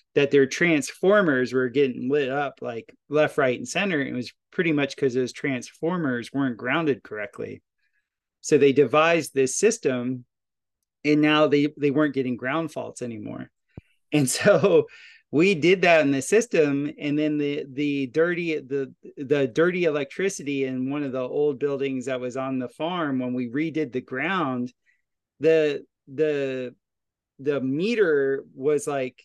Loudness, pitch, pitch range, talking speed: -23 LUFS, 145 Hz, 130-155 Hz, 155 wpm